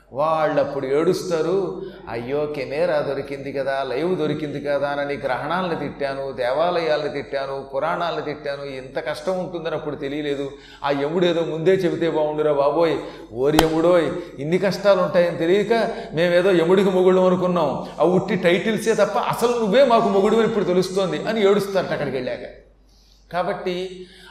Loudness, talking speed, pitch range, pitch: -21 LUFS, 135 wpm, 145-185 Hz, 165 Hz